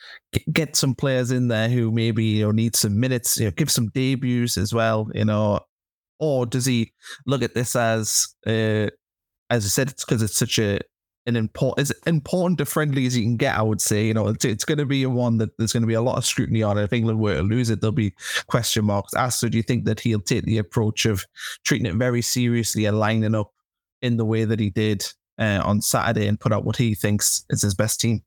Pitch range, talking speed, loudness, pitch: 110-125 Hz, 245 wpm, -22 LUFS, 115 Hz